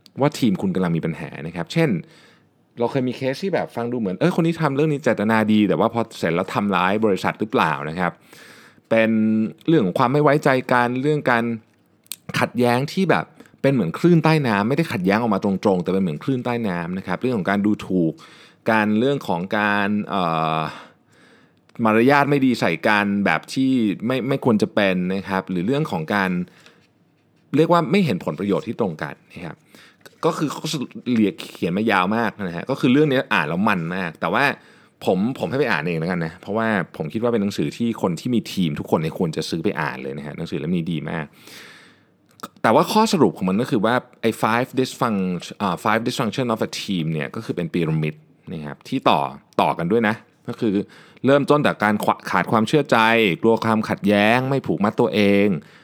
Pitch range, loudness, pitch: 100-135 Hz, -20 LUFS, 115 Hz